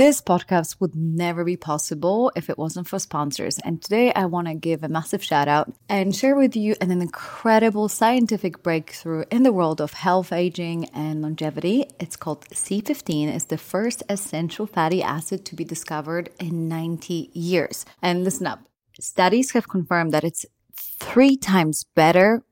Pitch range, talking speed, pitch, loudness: 160-200 Hz, 170 wpm, 175 Hz, -22 LUFS